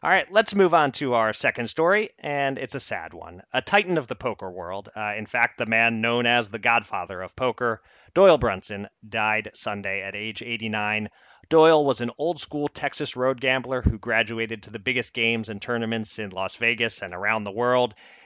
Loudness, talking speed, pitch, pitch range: -24 LUFS, 200 wpm, 115 Hz, 110-130 Hz